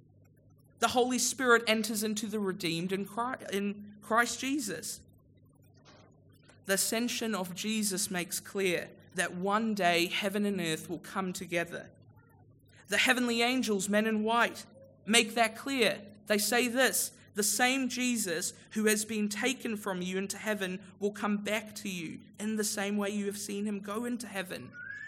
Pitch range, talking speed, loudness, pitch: 190-230 Hz, 155 wpm, -31 LUFS, 210 Hz